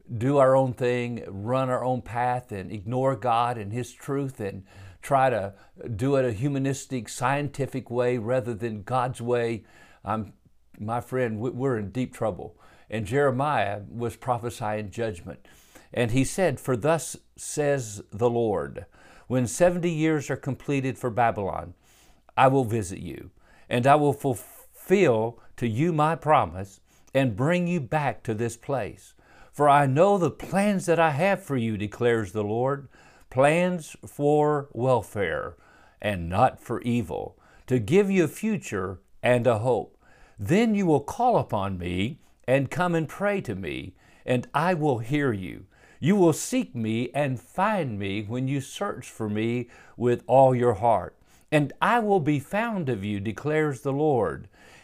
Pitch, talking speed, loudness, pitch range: 125 Hz, 160 wpm, -25 LUFS, 115-145 Hz